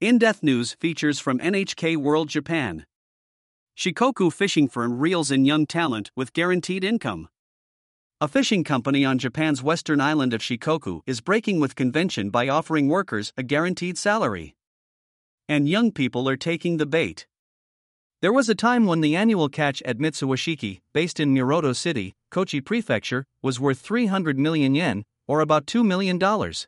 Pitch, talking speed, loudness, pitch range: 155 Hz, 155 wpm, -23 LUFS, 130-180 Hz